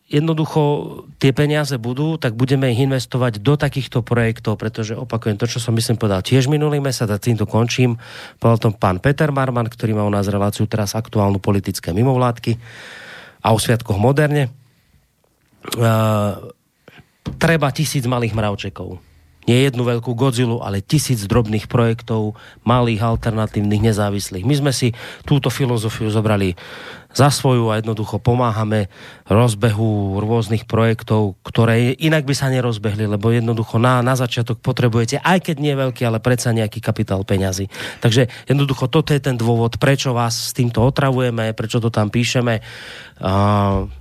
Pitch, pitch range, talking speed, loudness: 120 Hz, 110-130 Hz, 145 wpm, -18 LUFS